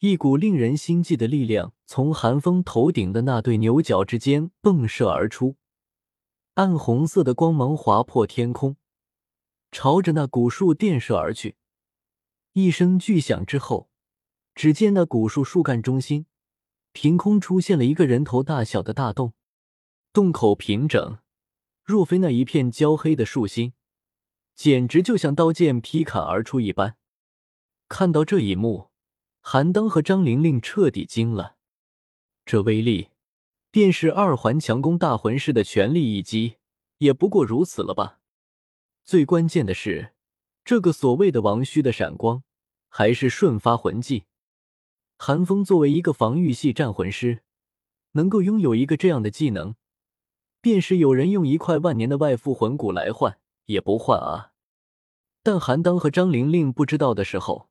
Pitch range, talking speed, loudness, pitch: 115-170 Hz, 225 characters per minute, -21 LUFS, 140 Hz